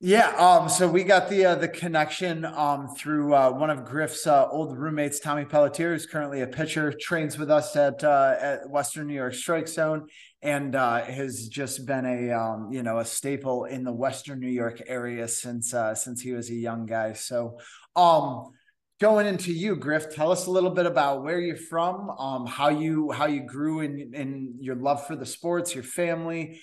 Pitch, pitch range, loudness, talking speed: 145 Hz, 130-165 Hz, -25 LUFS, 205 wpm